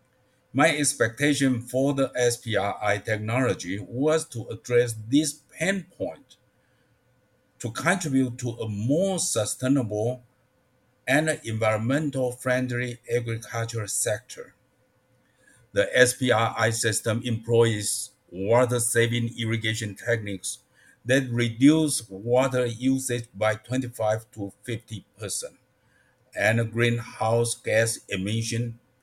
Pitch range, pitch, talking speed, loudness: 115-130 Hz, 120 Hz, 85 wpm, -25 LUFS